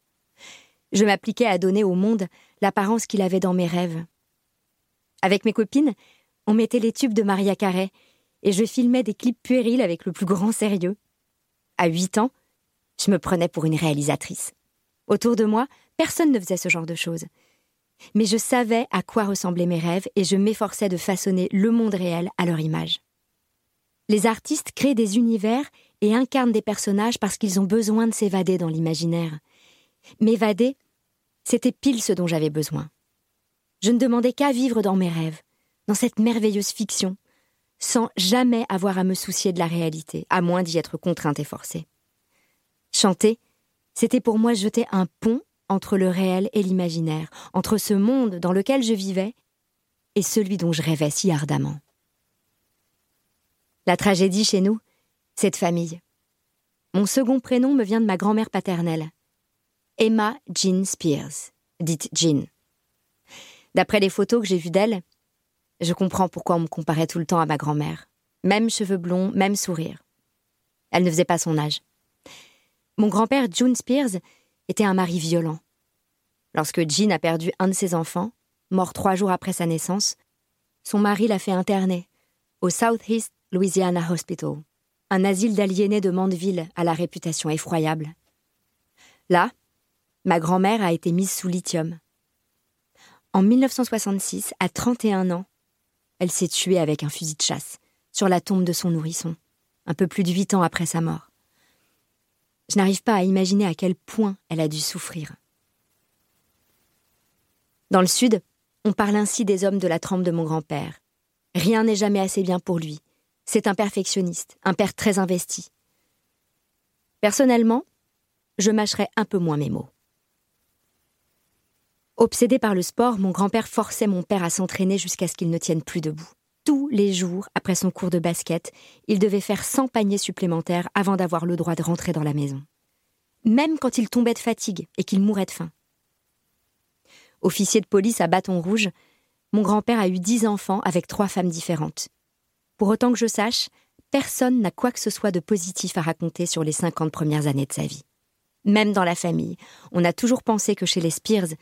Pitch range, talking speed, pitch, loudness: 175-220 Hz, 170 wpm, 195 Hz, -22 LUFS